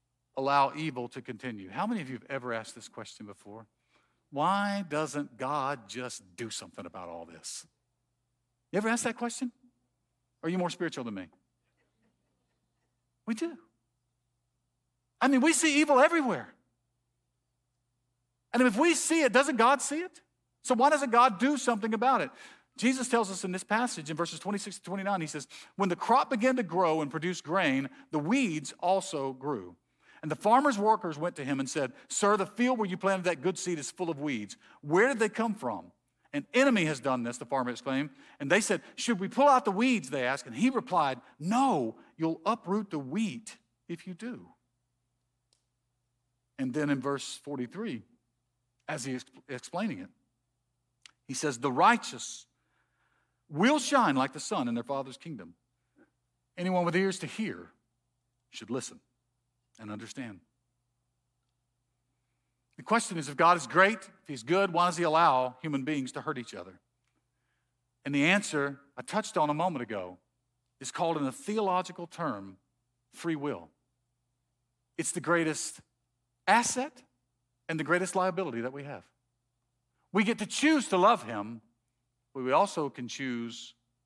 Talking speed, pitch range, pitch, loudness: 165 wpm, 120-200 Hz, 145 Hz, -29 LUFS